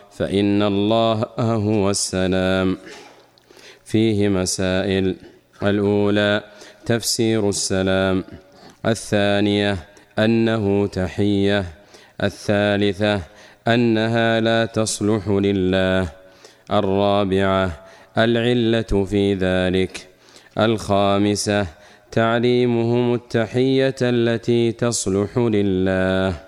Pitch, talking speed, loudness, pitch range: 100 Hz, 60 wpm, -19 LUFS, 95-115 Hz